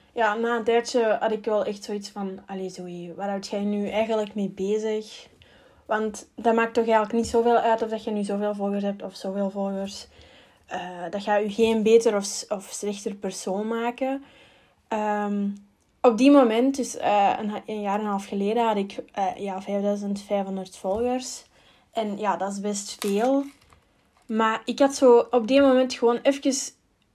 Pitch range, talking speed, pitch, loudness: 200-235 Hz, 180 wpm, 215 Hz, -24 LUFS